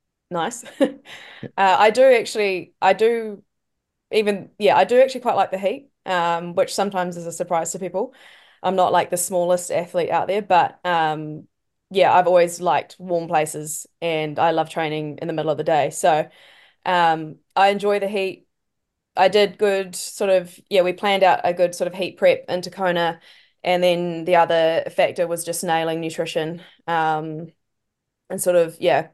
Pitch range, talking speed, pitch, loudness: 165-195 Hz, 180 wpm, 180 Hz, -20 LUFS